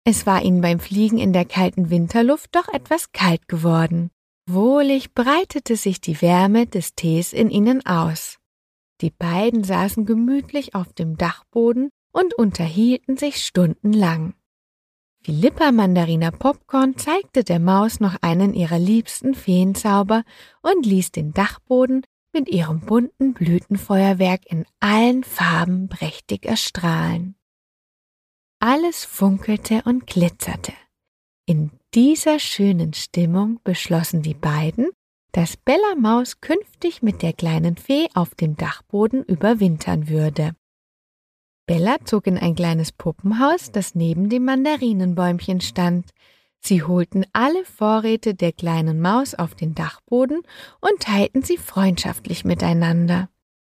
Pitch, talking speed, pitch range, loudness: 195 Hz, 120 wpm, 170-245 Hz, -19 LUFS